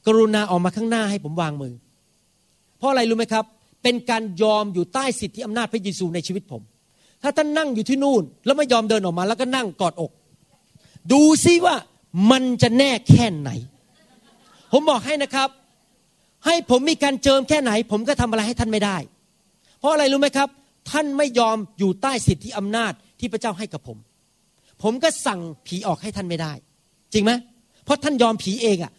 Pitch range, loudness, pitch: 185-265 Hz, -20 LUFS, 225 Hz